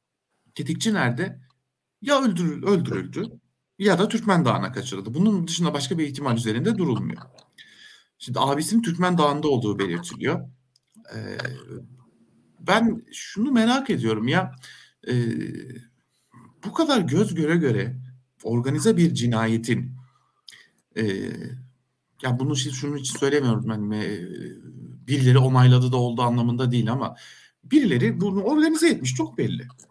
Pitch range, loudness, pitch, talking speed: 120-185 Hz, -23 LUFS, 135 Hz, 120 wpm